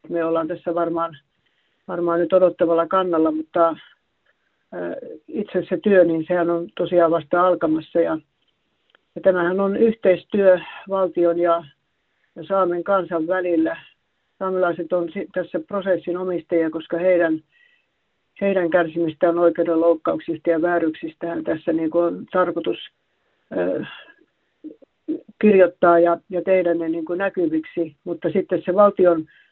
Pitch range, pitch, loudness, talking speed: 170-185 Hz, 175 Hz, -20 LUFS, 120 wpm